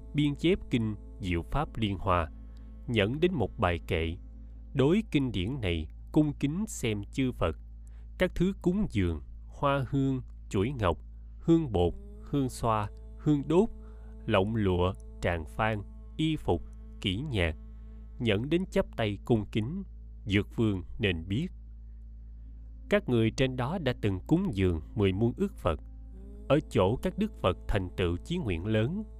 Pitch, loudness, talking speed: 105 Hz, -30 LUFS, 155 wpm